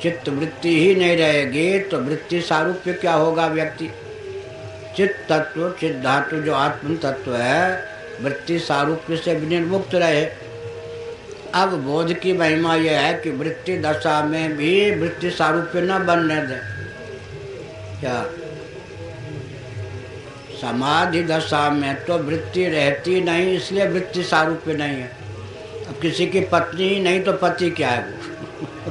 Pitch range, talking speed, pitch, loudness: 140-175 Hz, 130 wpm, 160 Hz, -20 LUFS